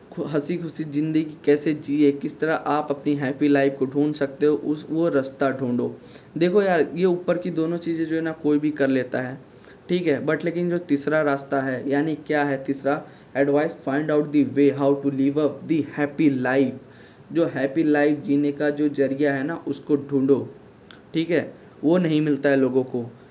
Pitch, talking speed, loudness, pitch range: 145 Hz, 200 wpm, -23 LUFS, 135-155 Hz